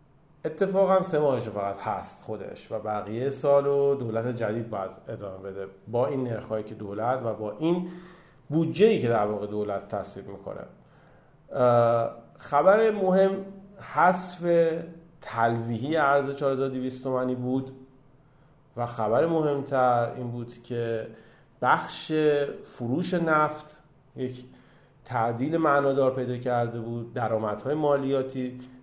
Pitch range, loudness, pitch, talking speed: 115-150 Hz, -26 LUFS, 130 Hz, 115 wpm